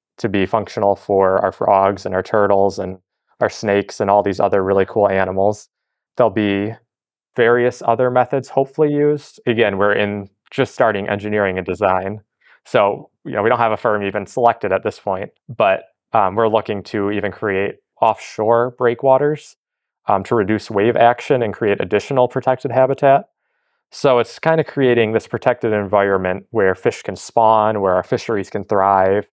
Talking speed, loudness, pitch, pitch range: 170 wpm, -17 LUFS, 105 Hz, 100-120 Hz